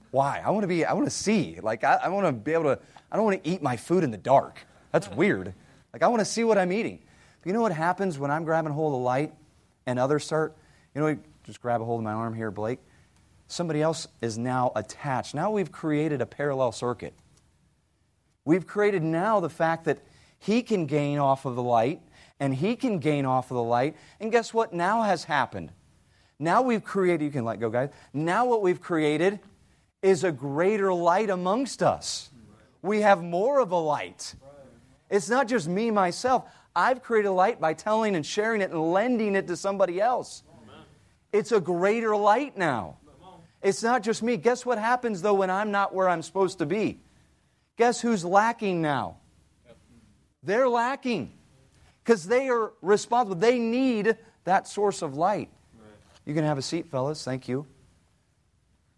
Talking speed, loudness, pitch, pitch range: 195 wpm, -26 LUFS, 170 Hz, 135-210 Hz